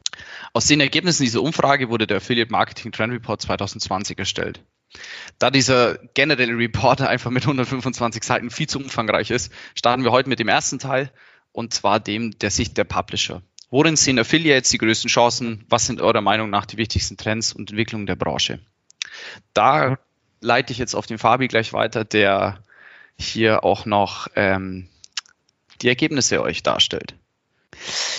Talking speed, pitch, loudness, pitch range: 165 wpm, 115 Hz, -20 LUFS, 105-125 Hz